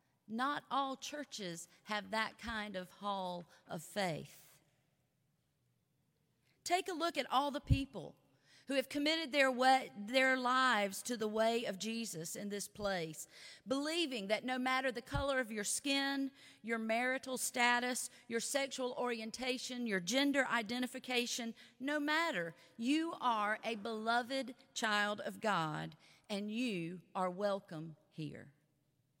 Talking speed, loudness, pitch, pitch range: 130 wpm, -37 LUFS, 230 Hz, 195-260 Hz